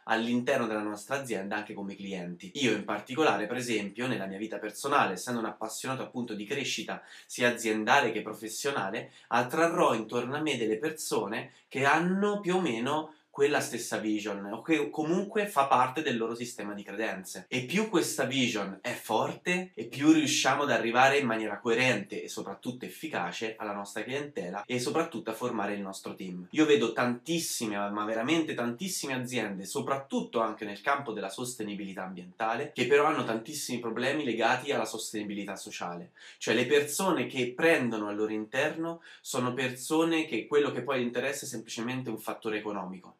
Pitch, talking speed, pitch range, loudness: 115 Hz, 165 wpm, 105-140 Hz, -30 LUFS